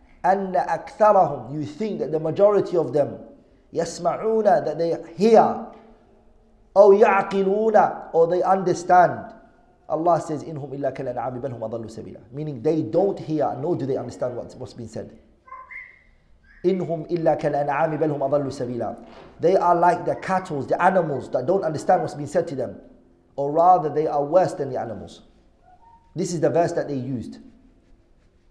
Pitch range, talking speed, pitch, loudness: 145-185 Hz, 160 wpm, 165 Hz, -21 LUFS